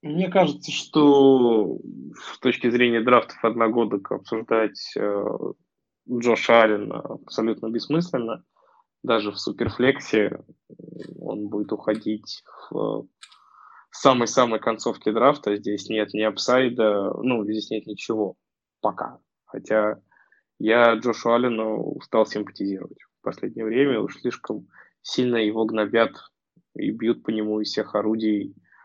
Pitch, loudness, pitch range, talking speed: 110 Hz, -23 LUFS, 105-125 Hz, 115 wpm